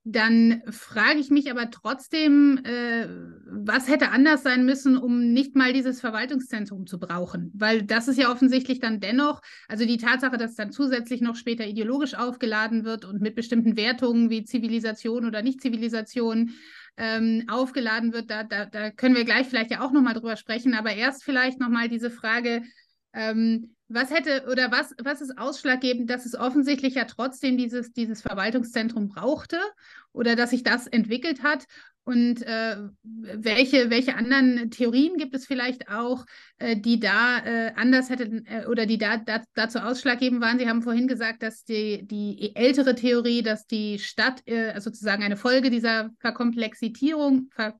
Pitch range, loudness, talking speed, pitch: 225-260 Hz, -24 LUFS, 165 wpm, 235 Hz